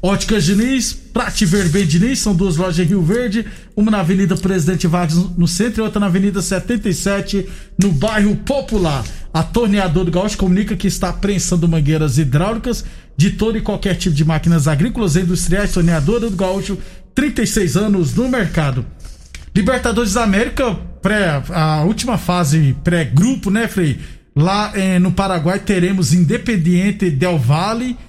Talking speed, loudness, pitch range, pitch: 160 wpm, -16 LUFS, 175-210 Hz, 190 Hz